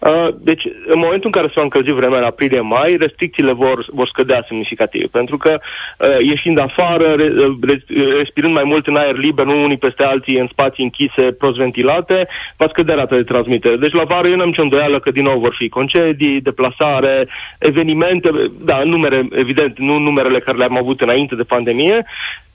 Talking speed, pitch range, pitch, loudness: 175 wpm, 130-160 Hz, 140 Hz, -14 LUFS